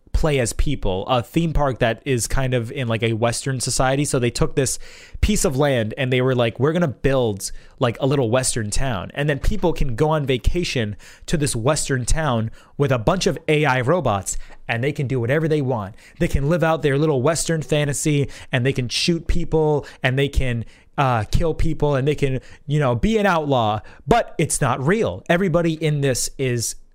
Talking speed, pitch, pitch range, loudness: 205 wpm, 135 Hz, 120-155 Hz, -21 LUFS